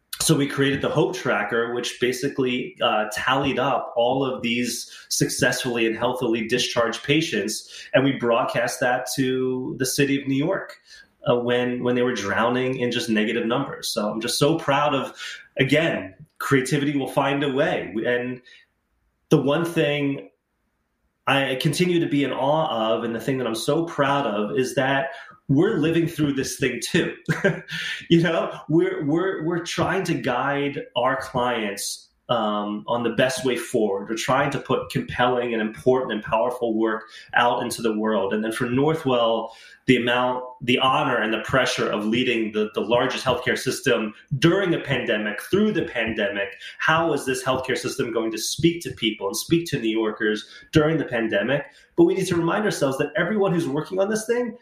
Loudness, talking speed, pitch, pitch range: -23 LUFS, 180 wpm, 130 Hz, 115-150 Hz